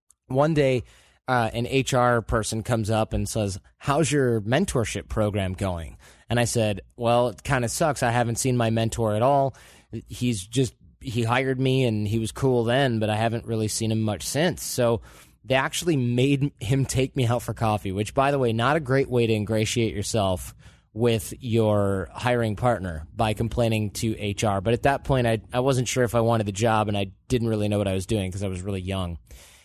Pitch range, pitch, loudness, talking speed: 105-125 Hz, 115 Hz, -24 LUFS, 210 wpm